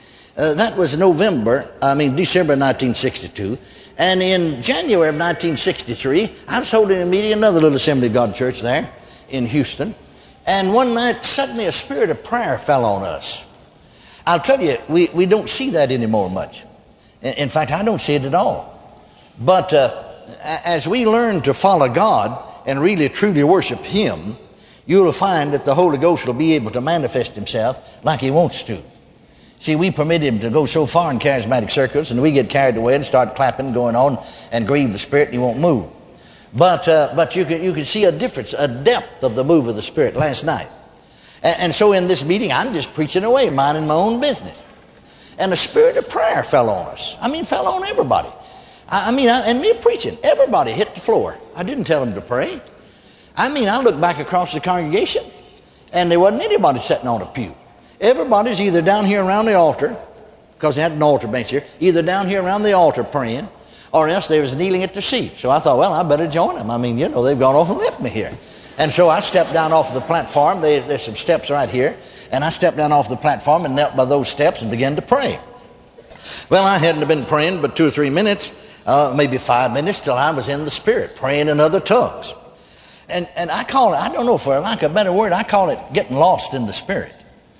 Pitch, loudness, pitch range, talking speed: 165 Hz, -17 LUFS, 145-195 Hz, 215 wpm